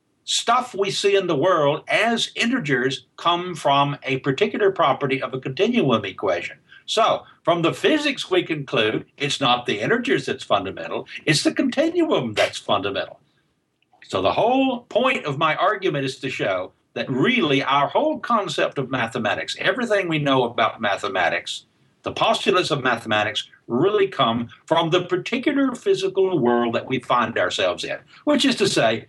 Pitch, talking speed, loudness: 180 Hz, 155 wpm, -21 LUFS